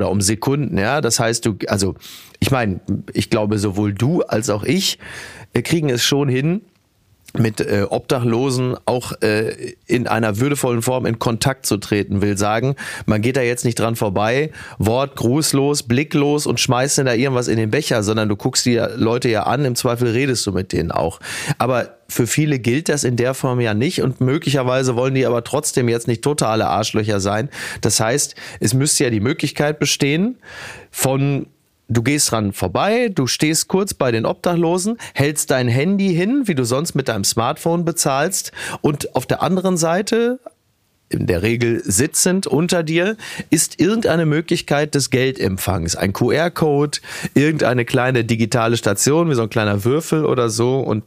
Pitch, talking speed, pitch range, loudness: 125 Hz, 170 wpm, 115-150 Hz, -18 LUFS